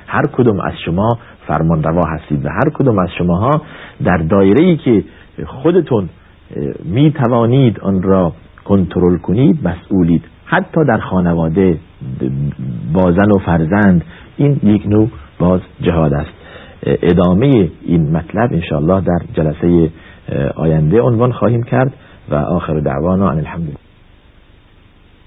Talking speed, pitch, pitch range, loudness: 120 wpm, 90 Hz, 85-105 Hz, -14 LUFS